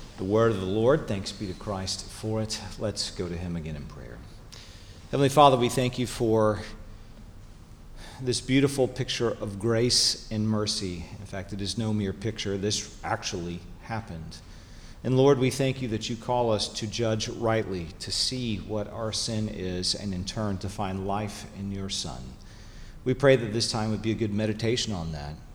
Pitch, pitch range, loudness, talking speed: 105 Hz, 95-115 Hz, -27 LUFS, 190 wpm